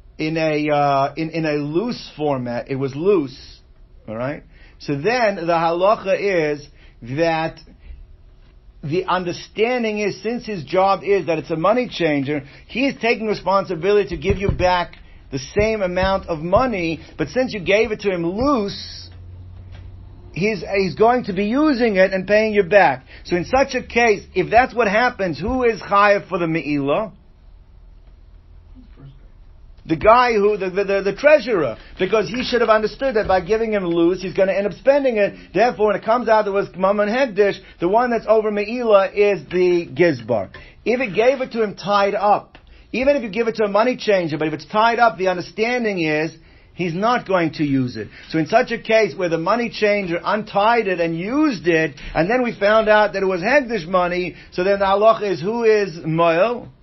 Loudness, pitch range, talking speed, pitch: -19 LUFS, 165-220 Hz, 190 wpm, 195 Hz